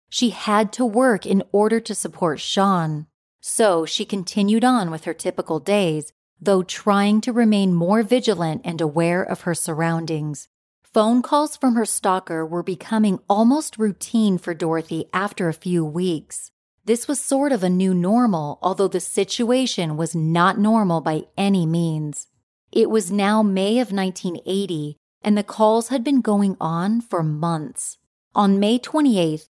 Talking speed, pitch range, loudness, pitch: 155 wpm, 170-220 Hz, -20 LUFS, 195 Hz